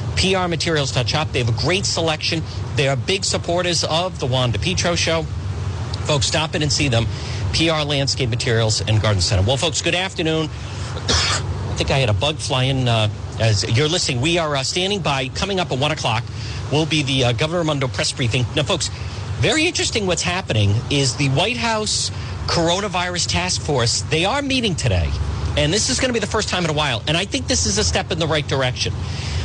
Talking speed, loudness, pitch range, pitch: 210 wpm, -19 LUFS, 105-155 Hz, 125 Hz